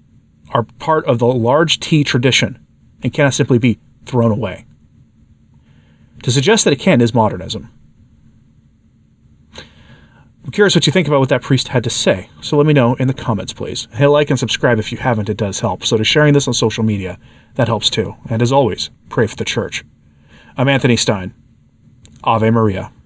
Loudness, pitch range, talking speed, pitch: -15 LUFS, 110-140 Hz, 190 wpm, 120 Hz